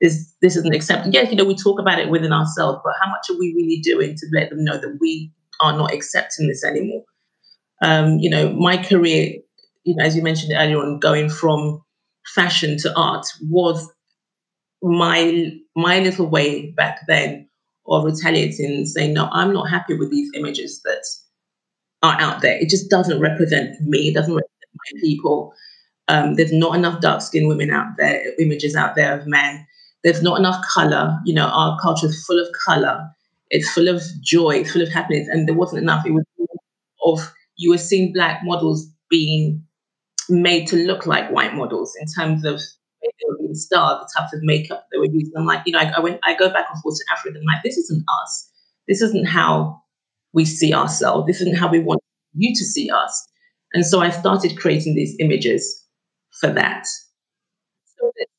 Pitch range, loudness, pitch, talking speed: 155-190 Hz, -18 LUFS, 170 Hz, 195 wpm